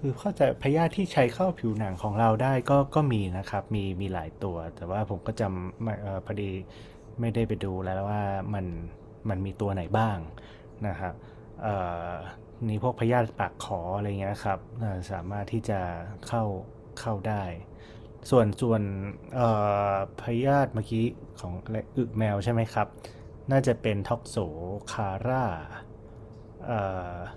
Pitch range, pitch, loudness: 95-115 Hz, 110 Hz, -29 LUFS